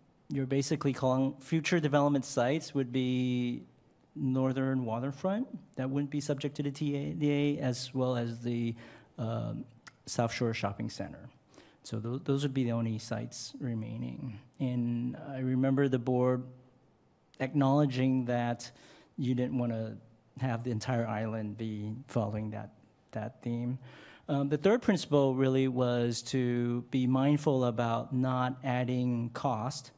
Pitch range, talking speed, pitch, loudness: 120-140 Hz, 135 wpm, 130 Hz, -32 LUFS